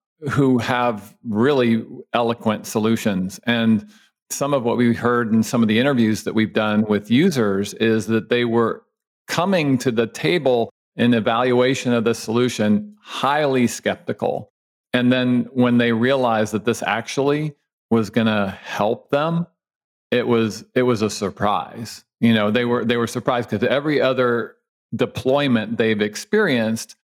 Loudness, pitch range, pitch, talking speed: -20 LUFS, 110-125 Hz, 120 Hz, 150 wpm